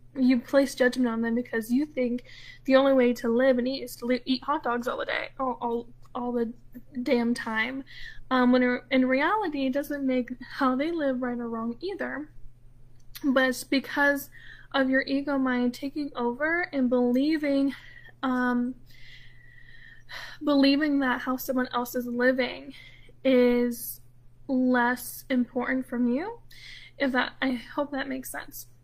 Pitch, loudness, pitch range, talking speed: 255 Hz, -27 LUFS, 245-275 Hz, 155 wpm